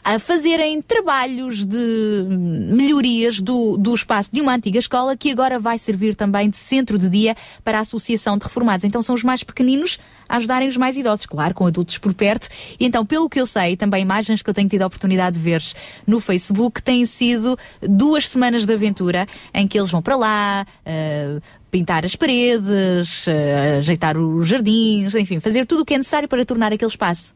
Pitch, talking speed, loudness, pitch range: 220 Hz, 195 wpm, -18 LUFS, 190-250 Hz